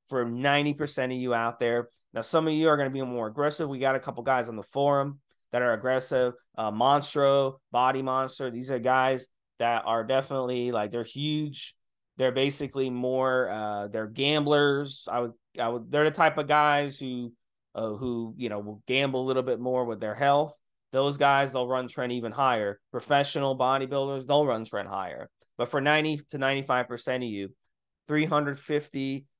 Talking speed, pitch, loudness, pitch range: 185 wpm, 130 Hz, -27 LUFS, 120-140 Hz